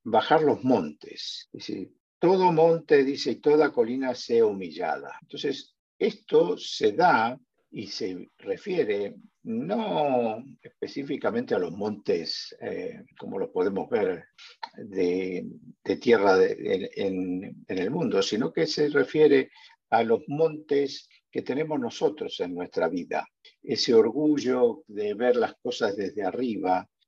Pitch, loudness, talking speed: 165 Hz, -26 LUFS, 130 wpm